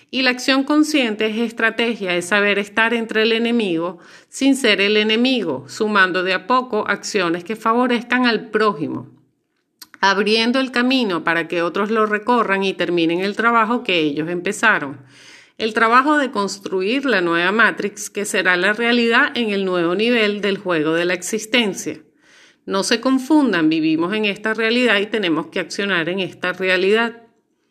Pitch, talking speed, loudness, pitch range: 220 Hz, 160 wpm, -18 LUFS, 190-245 Hz